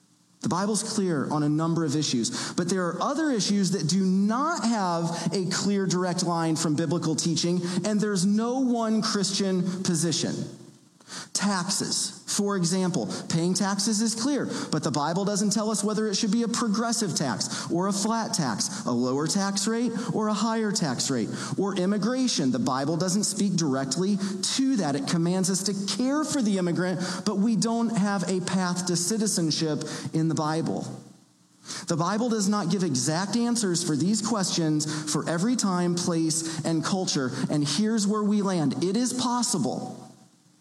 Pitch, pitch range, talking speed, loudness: 195 Hz, 170-215 Hz, 170 wpm, -26 LUFS